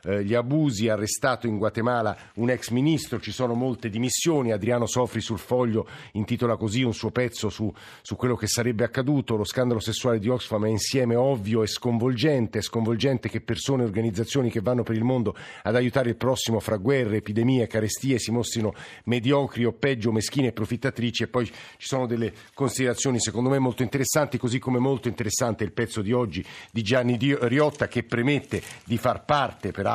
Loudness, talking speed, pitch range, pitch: -25 LUFS, 180 wpm, 110-130 Hz, 120 Hz